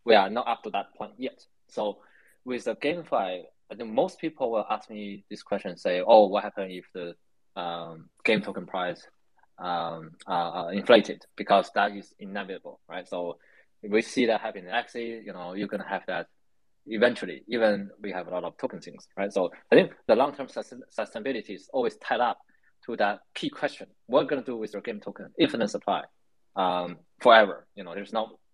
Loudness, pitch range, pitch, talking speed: -27 LUFS, 90-110 Hz, 100 Hz, 200 wpm